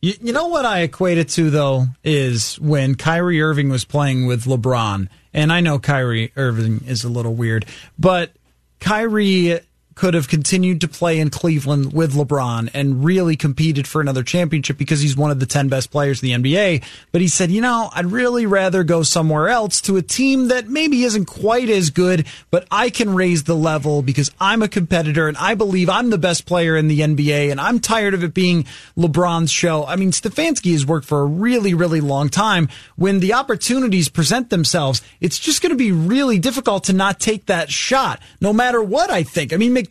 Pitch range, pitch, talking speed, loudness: 145-195 Hz, 170 Hz, 205 wpm, -17 LUFS